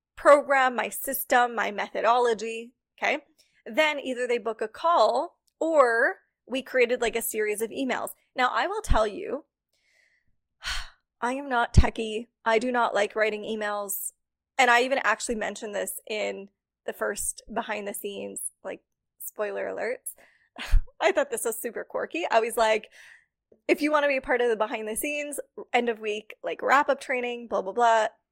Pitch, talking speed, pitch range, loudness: 235 Hz, 170 wpm, 220-275 Hz, -26 LUFS